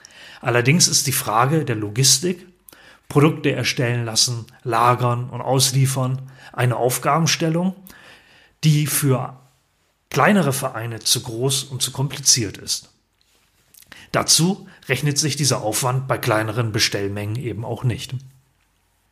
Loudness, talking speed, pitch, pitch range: -19 LUFS, 110 wpm, 130 Hz, 120-145 Hz